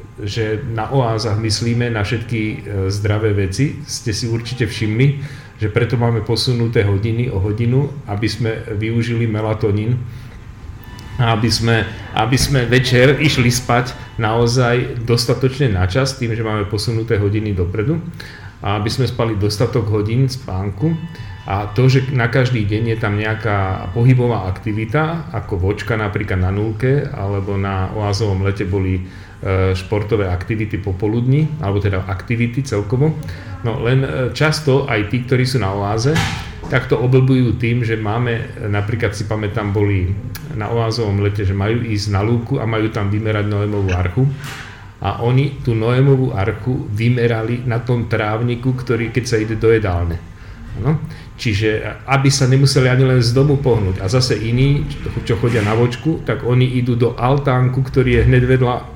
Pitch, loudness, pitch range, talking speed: 115 Hz, -17 LUFS, 105-125 Hz, 150 wpm